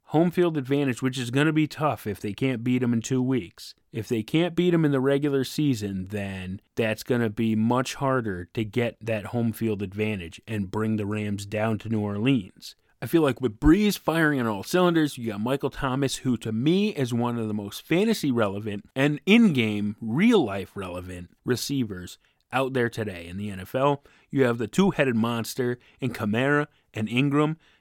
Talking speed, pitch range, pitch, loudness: 190 wpm, 110-140 Hz, 120 Hz, -25 LUFS